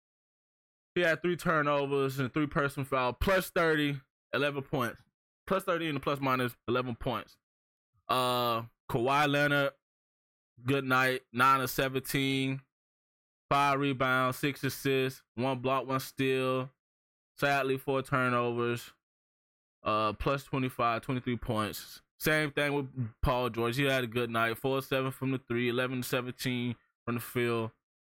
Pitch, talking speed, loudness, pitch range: 130 Hz, 140 wpm, -31 LUFS, 120-140 Hz